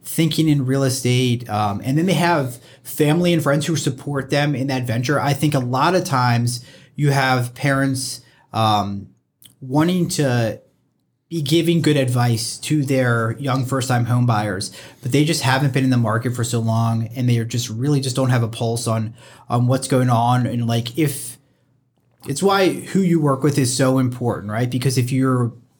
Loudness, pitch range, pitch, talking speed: -19 LUFS, 120-145 Hz, 130 Hz, 190 wpm